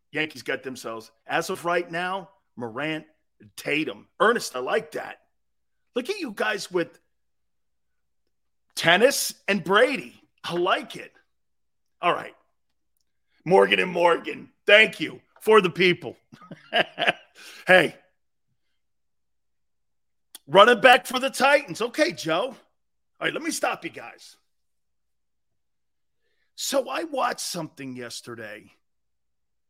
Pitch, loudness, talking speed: 180 Hz, -22 LUFS, 110 wpm